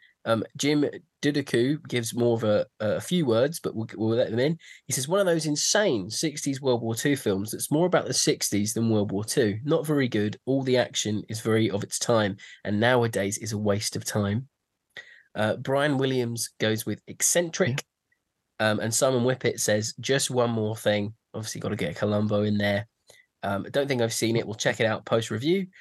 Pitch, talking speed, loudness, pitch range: 115 Hz, 205 wpm, -26 LUFS, 105-140 Hz